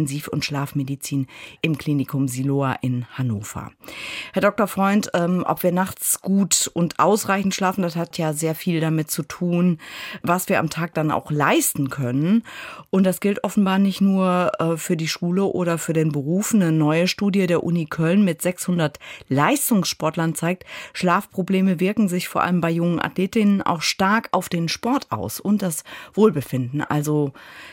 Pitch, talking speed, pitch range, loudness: 170 Hz, 160 wpm, 150-190 Hz, -21 LUFS